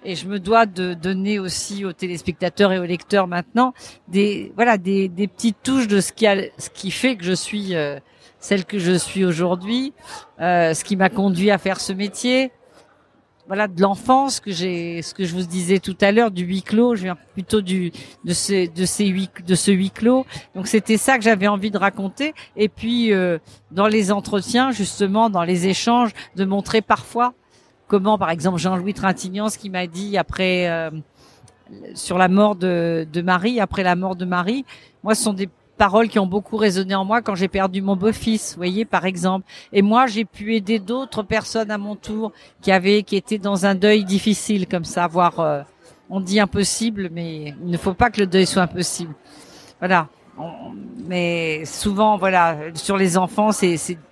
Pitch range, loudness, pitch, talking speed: 180-215 Hz, -20 LUFS, 195 Hz, 200 wpm